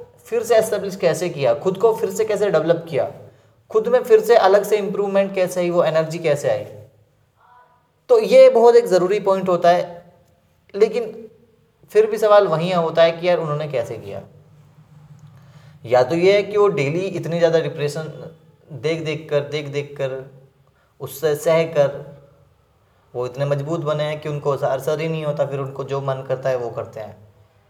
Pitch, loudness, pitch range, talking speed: 160 Hz, -18 LUFS, 145-195 Hz, 180 wpm